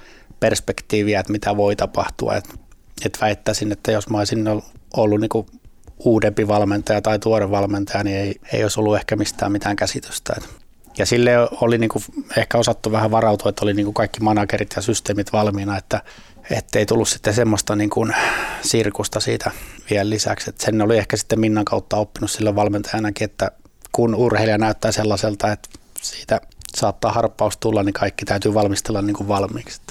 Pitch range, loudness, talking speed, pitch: 100-110 Hz, -20 LUFS, 165 wpm, 105 Hz